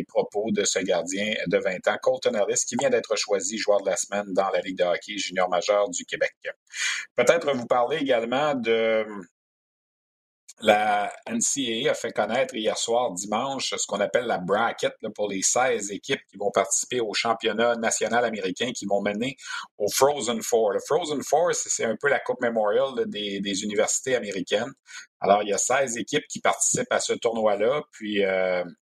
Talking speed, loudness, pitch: 180 wpm, -25 LUFS, 120 Hz